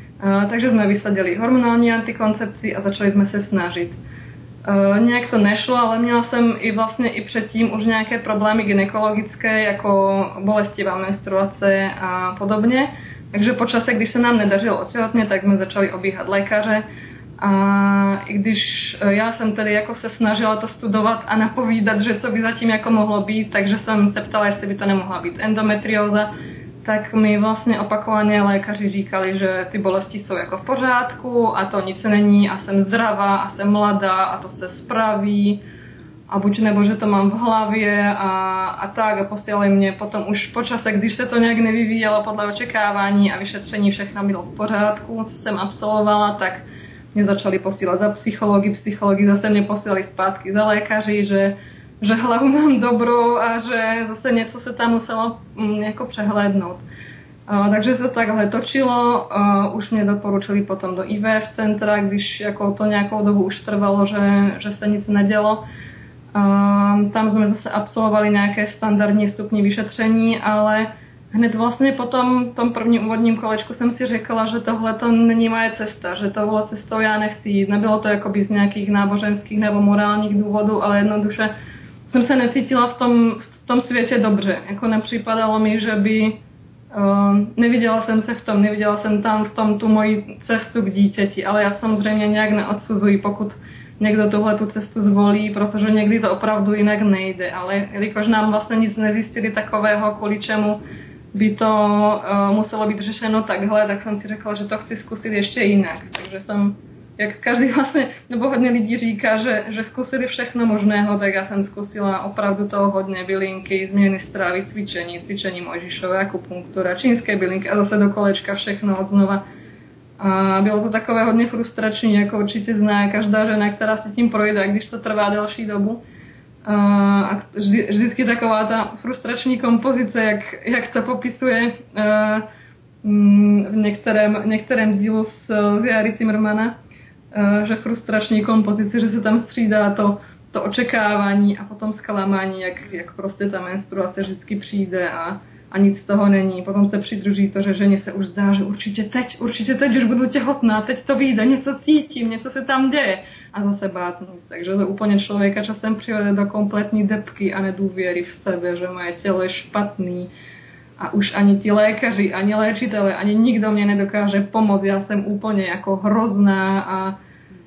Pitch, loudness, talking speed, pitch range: 210 Hz, -19 LUFS, 165 wpm, 200-220 Hz